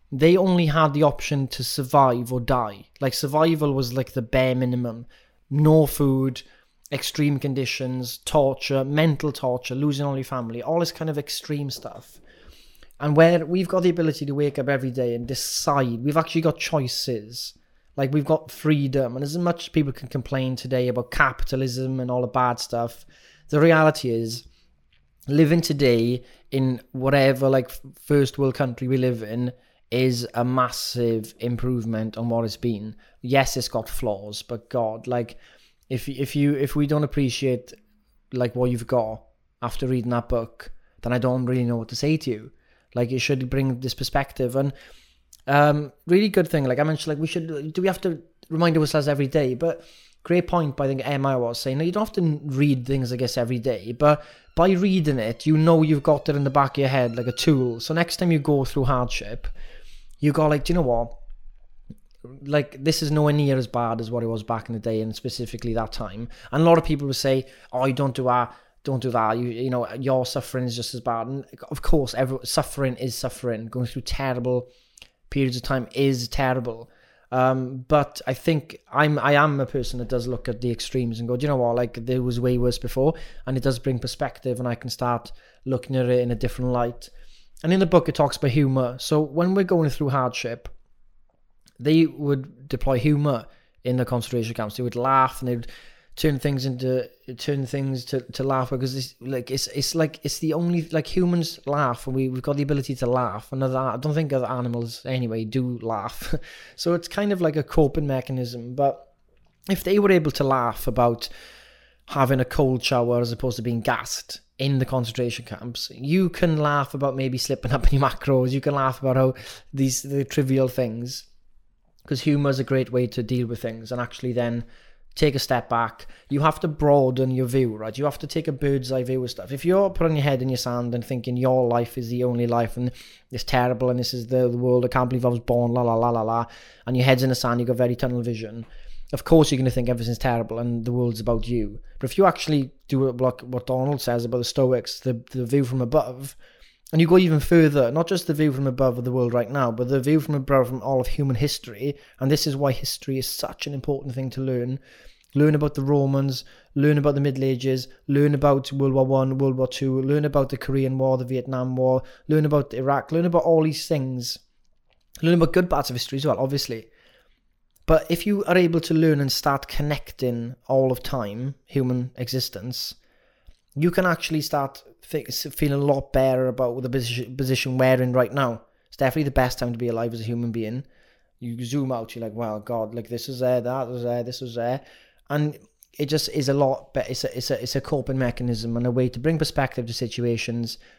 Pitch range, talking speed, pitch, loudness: 125-145 Hz, 215 wpm, 130 Hz, -23 LUFS